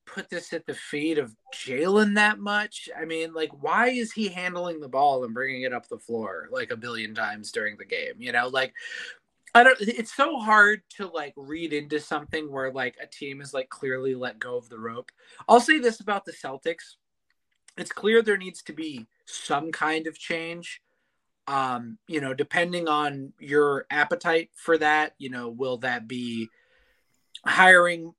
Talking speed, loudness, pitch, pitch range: 185 wpm, -25 LUFS, 165 Hz, 140-210 Hz